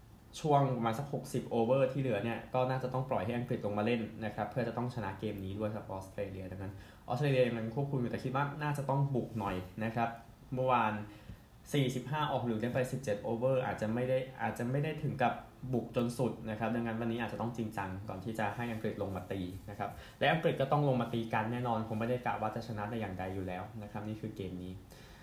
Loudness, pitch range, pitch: -35 LUFS, 105-130 Hz, 115 Hz